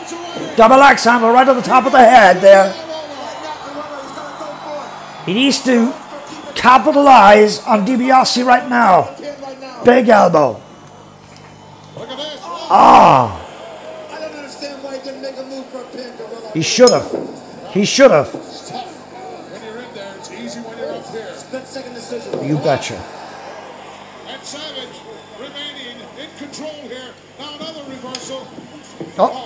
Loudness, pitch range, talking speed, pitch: -11 LUFS, 245-280 Hz, 130 wpm, 260 Hz